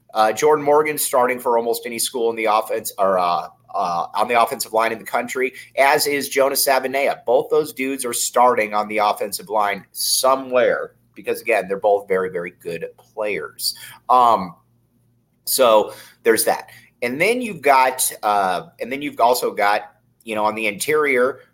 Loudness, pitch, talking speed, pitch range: -19 LUFS, 130 Hz, 175 wpm, 115-155 Hz